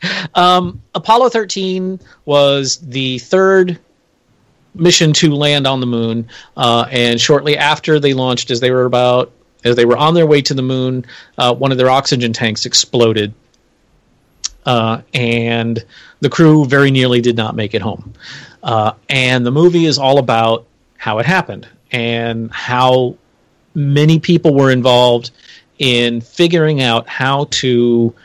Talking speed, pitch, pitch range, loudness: 150 wpm, 130 Hz, 120-150 Hz, -13 LUFS